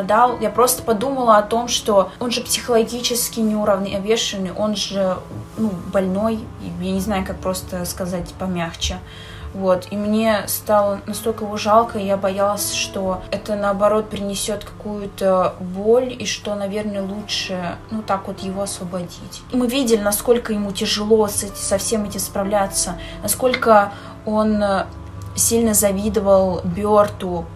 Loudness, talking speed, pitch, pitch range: -19 LUFS, 135 wpm, 205 Hz, 190-220 Hz